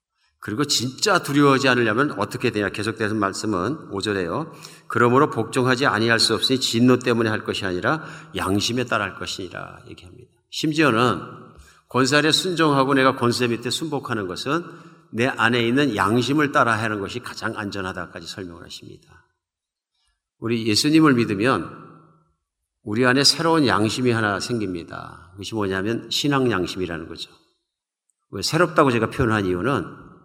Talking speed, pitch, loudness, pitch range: 345 characters per minute, 120 Hz, -21 LUFS, 105-135 Hz